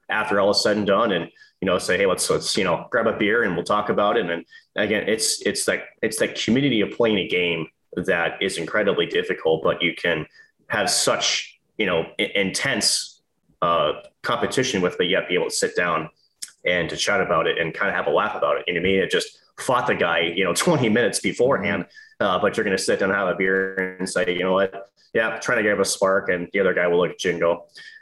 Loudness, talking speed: -21 LUFS, 245 wpm